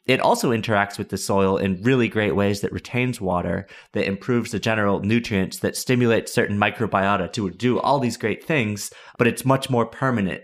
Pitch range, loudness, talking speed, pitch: 100-120 Hz, -22 LUFS, 190 wpm, 105 Hz